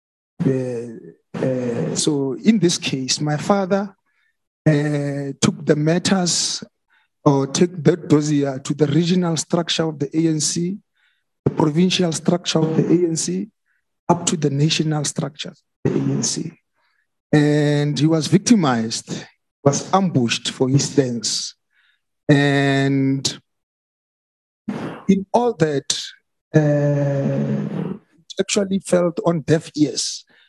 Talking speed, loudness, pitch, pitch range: 115 wpm, -19 LUFS, 155 Hz, 140-175 Hz